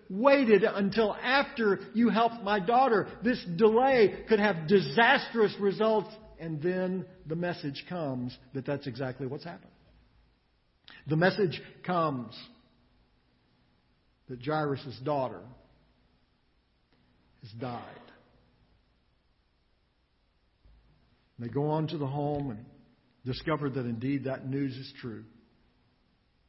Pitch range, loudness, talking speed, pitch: 130-205 Hz, -29 LUFS, 105 wpm, 155 Hz